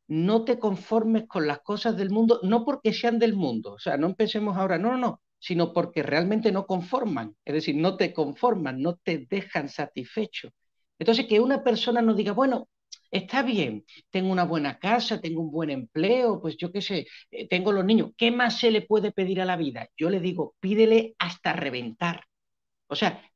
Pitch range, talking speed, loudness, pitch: 170-225 Hz, 195 wpm, -26 LUFS, 195 Hz